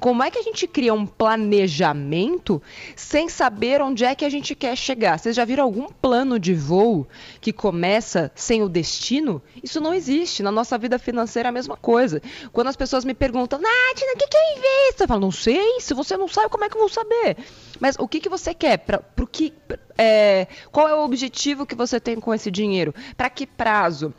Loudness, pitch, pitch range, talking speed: -21 LUFS, 250 Hz, 220-305 Hz, 220 wpm